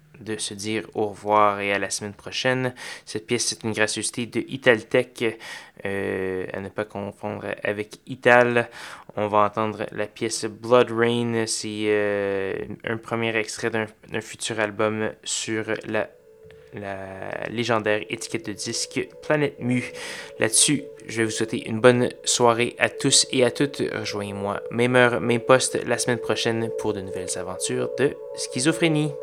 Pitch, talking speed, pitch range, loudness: 110 Hz, 155 wpm, 105-120 Hz, -23 LUFS